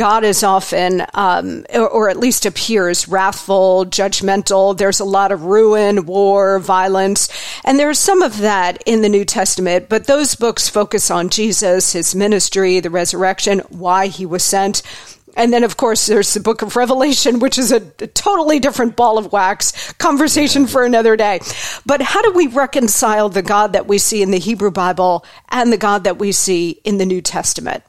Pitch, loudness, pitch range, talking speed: 205 Hz, -14 LUFS, 190-240 Hz, 185 wpm